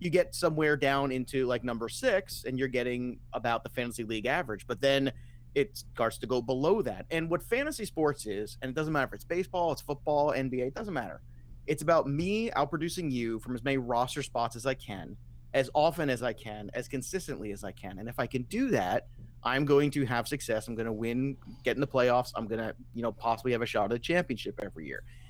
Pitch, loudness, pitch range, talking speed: 125 Hz, -31 LUFS, 115-145 Hz, 230 wpm